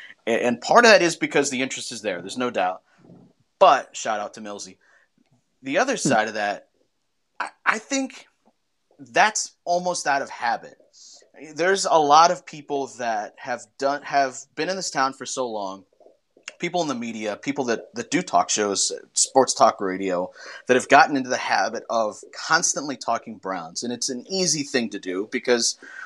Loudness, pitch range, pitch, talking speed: -22 LUFS, 105-150 Hz, 125 Hz, 180 wpm